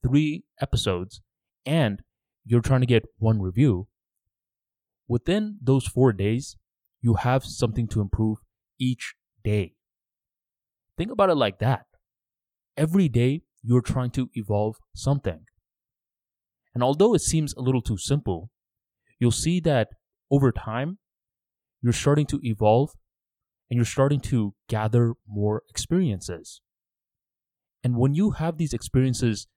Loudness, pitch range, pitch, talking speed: -25 LUFS, 105-135 Hz, 120 Hz, 125 wpm